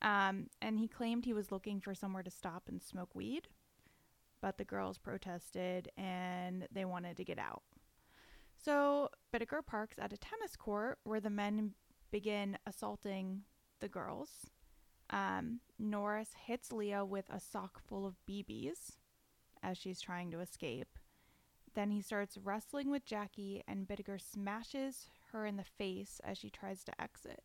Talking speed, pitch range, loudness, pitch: 155 wpm, 190-220 Hz, -43 LUFS, 205 Hz